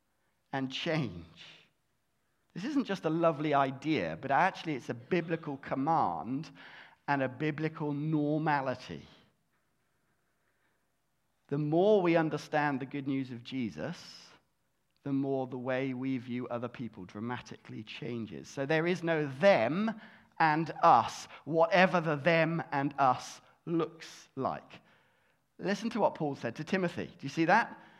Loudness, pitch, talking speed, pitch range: -31 LUFS, 150 Hz, 135 wpm, 130-165 Hz